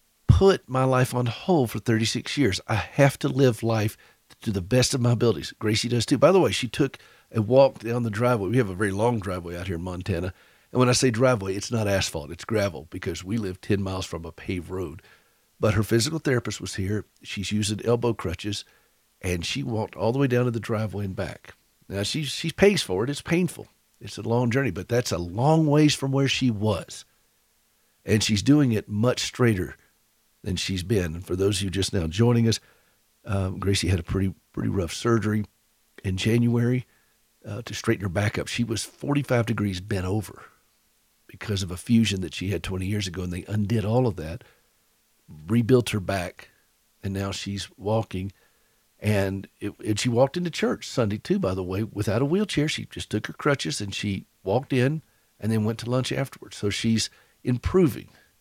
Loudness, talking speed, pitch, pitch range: -25 LUFS, 205 wpm, 110 Hz, 100-125 Hz